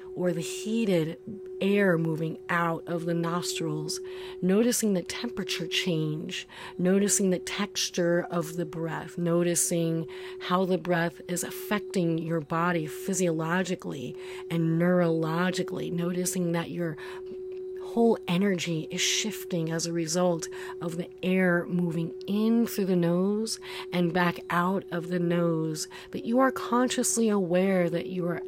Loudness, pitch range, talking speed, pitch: -28 LUFS, 170-185 Hz, 130 wpm, 180 Hz